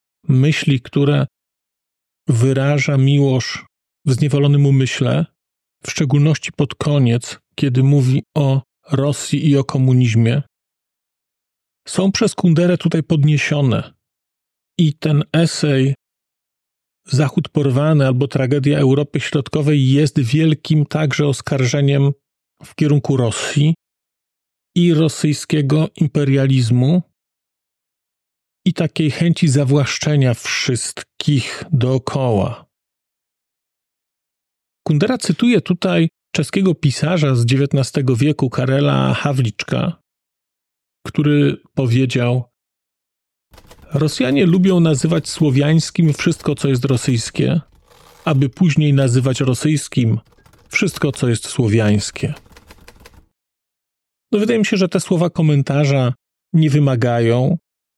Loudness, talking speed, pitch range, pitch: -16 LUFS, 90 wpm, 130-155 Hz, 145 Hz